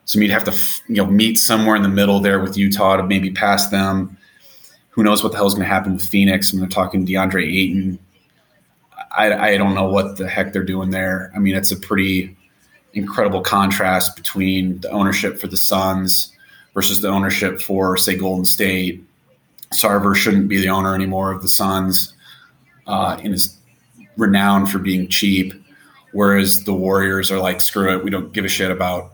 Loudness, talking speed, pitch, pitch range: -16 LUFS, 195 wpm, 95 Hz, 95-100 Hz